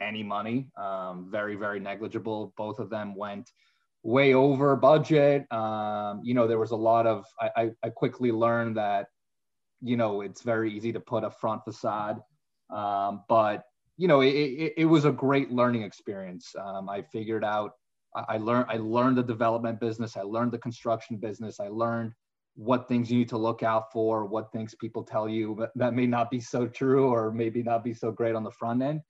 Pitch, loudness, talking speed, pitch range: 115 Hz, -28 LUFS, 200 wpm, 105-120 Hz